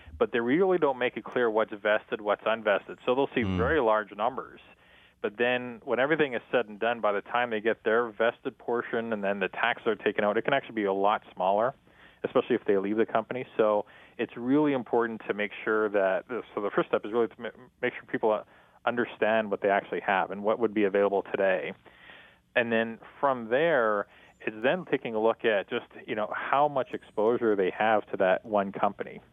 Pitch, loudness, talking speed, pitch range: 110 Hz, -28 LUFS, 215 wpm, 105-120 Hz